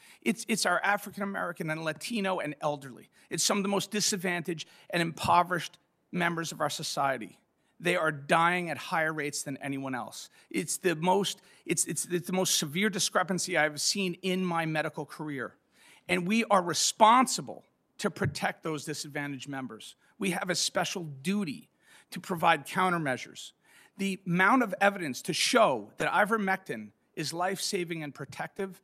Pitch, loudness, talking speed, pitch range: 175 Hz, -29 LUFS, 160 wpm, 155-190 Hz